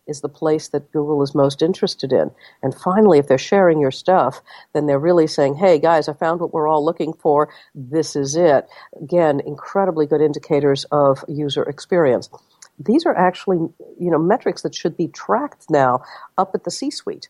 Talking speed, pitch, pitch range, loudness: 190 wpm, 155 Hz, 145-175 Hz, -18 LUFS